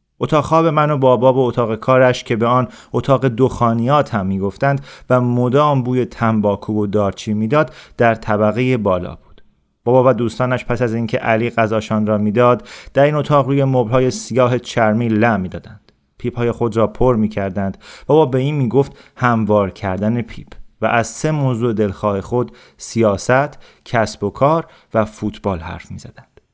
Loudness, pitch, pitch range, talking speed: -16 LUFS, 120 Hz, 105-130 Hz, 170 wpm